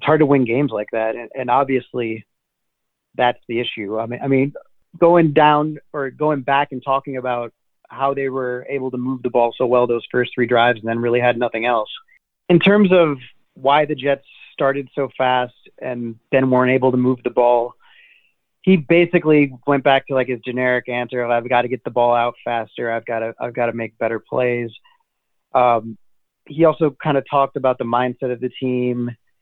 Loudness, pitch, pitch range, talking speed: -18 LUFS, 125 Hz, 120-140 Hz, 205 wpm